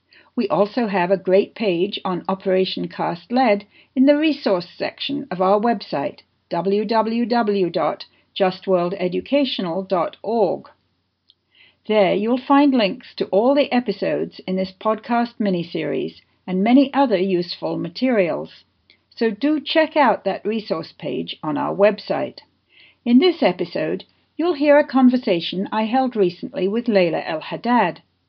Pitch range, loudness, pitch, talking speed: 190-255 Hz, -20 LUFS, 205 Hz, 125 wpm